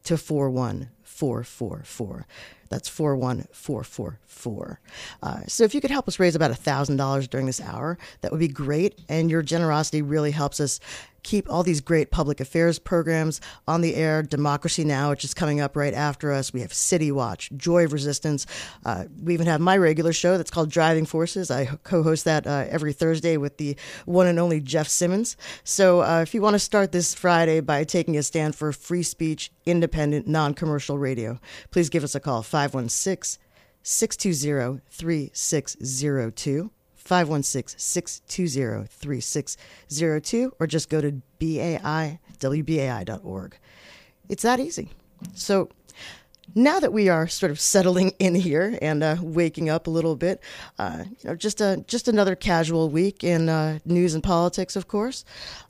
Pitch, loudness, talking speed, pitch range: 160 Hz, -24 LUFS, 160 wpm, 145-175 Hz